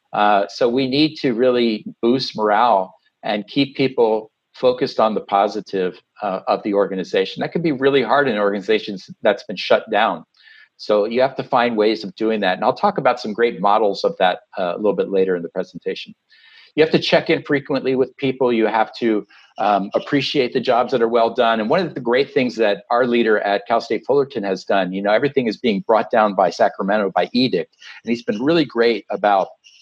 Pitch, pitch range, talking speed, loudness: 115 Hz, 105-135 Hz, 215 wpm, -19 LUFS